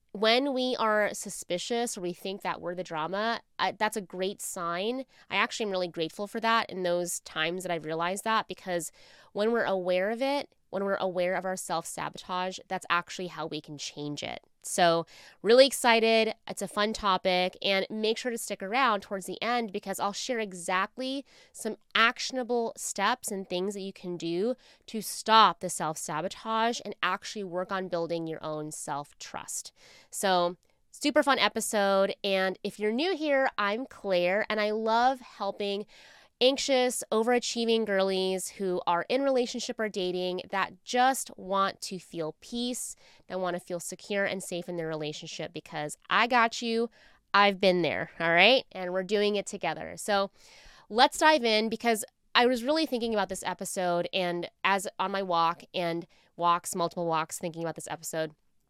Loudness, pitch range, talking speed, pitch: -29 LUFS, 175-225 Hz, 175 wpm, 195 Hz